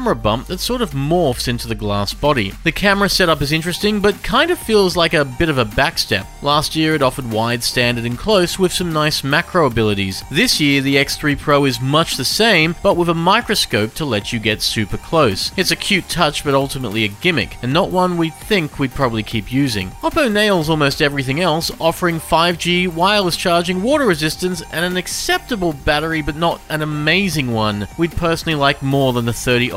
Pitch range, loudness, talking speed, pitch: 130-180 Hz, -16 LUFS, 205 wpm, 155 Hz